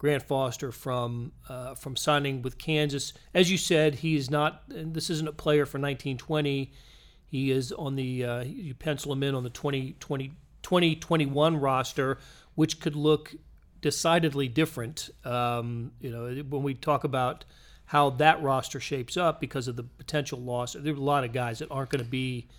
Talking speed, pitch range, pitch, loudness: 185 wpm, 130-150 Hz, 140 Hz, -28 LUFS